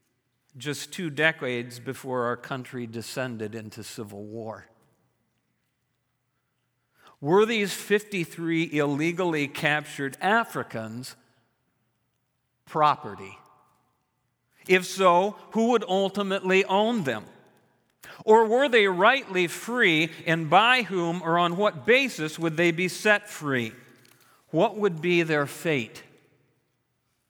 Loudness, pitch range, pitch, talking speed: -24 LUFS, 125-185 Hz, 150 Hz, 100 wpm